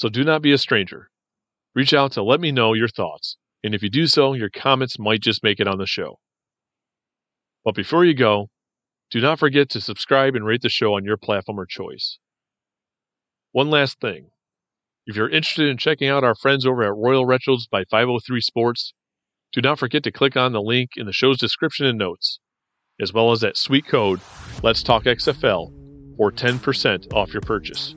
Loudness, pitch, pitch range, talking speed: -19 LUFS, 125 Hz, 110-140 Hz, 195 wpm